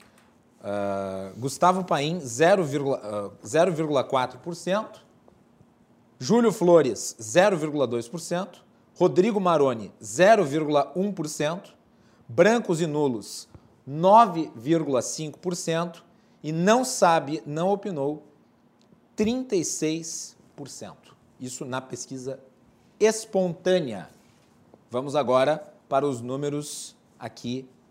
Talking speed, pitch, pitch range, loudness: 65 wpm, 155 Hz, 130-180 Hz, -24 LUFS